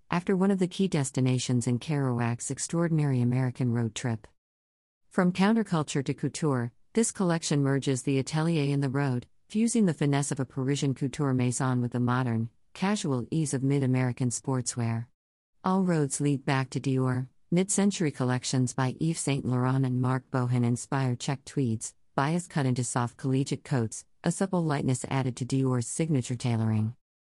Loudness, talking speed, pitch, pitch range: -28 LUFS, 155 wpm, 135 Hz, 125-150 Hz